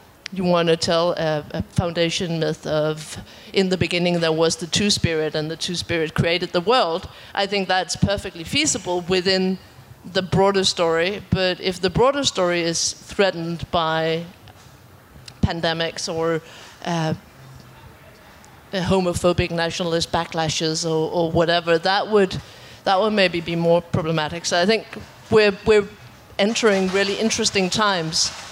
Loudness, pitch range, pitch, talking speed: -21 LUFS, 165-190 Hz, 175 Hz, 145 wpm